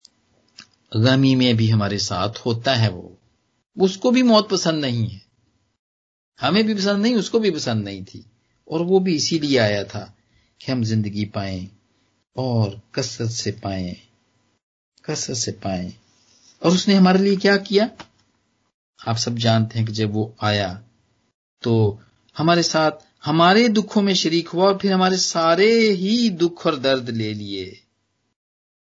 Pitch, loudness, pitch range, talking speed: 120 Hz, -20 LUFS, 110-175 Hz, 155 wpm